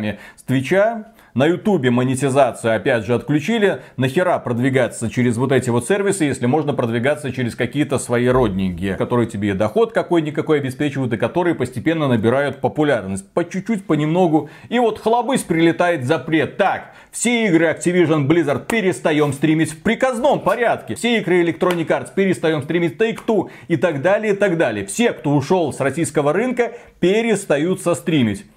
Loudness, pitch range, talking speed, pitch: -18 LUFS, 130-185 Hz, 150 wpm, 160 Hz